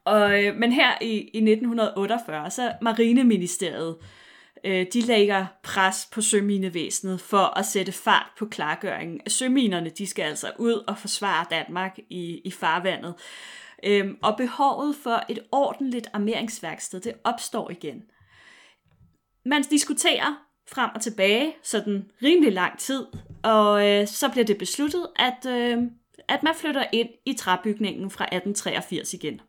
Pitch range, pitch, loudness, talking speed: 195-240 Hz, 215 Hz, -24 LUFS, 120 wpm